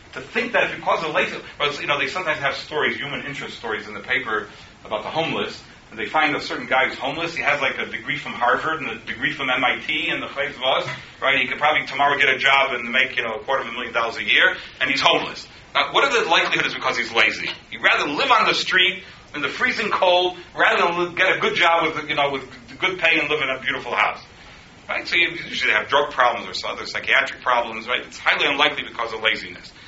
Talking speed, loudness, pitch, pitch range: 255 wpm, -20 LUFS, 140 Hz, 130-170 Hz